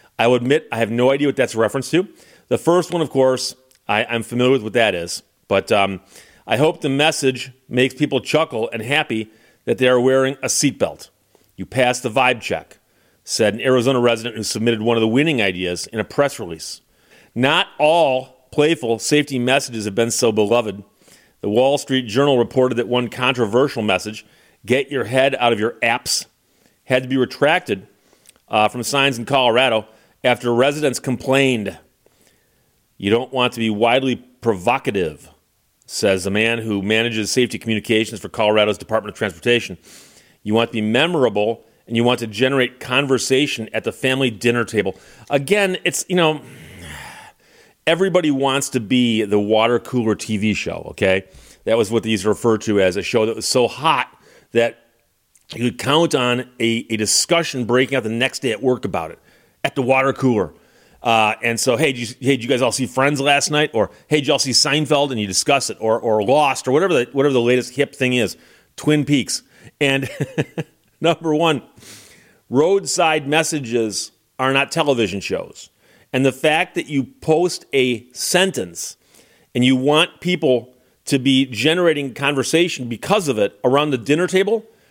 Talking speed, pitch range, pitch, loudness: 180 wpm, 115-140 Hz, 125 Hz, -18 LUFS